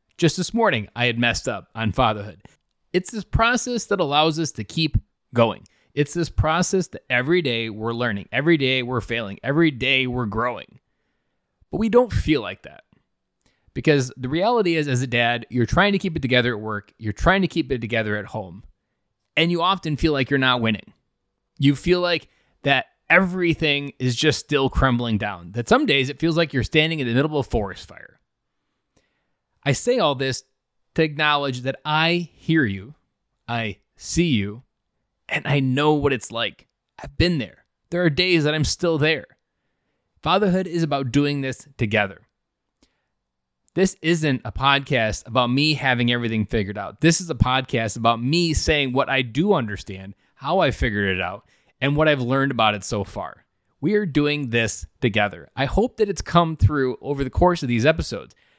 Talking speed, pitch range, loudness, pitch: 185 wpm, 115-160 Hz, -21 LUFS, 135 Hz